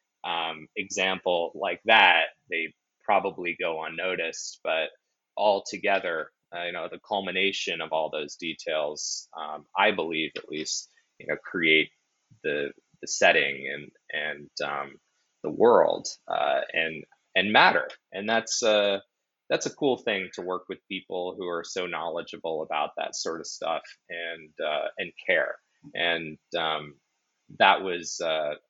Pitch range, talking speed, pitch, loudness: 80-95 Hz, 145 wpm, 85 Hz, -27 LUFS